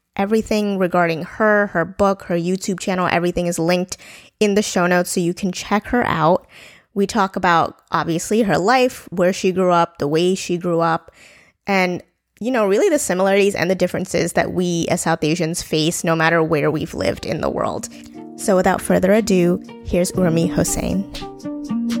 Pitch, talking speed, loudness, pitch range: 180 Hz, 180 wpm, -18 LUFS, 170-200 Hz